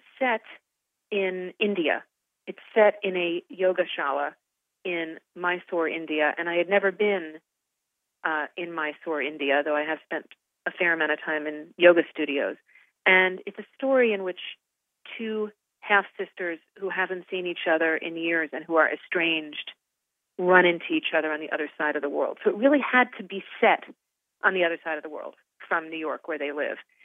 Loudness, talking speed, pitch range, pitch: -25 LUFS, 185 wpm, 155-195 Hz, 175 Hz